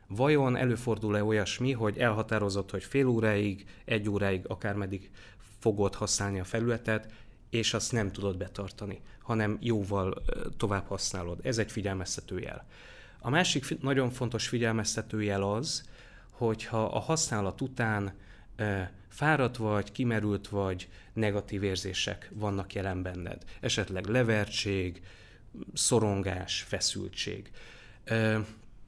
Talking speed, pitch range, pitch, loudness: 115 wpm, 100-115 Hz, 105 Hz, -31 LUFS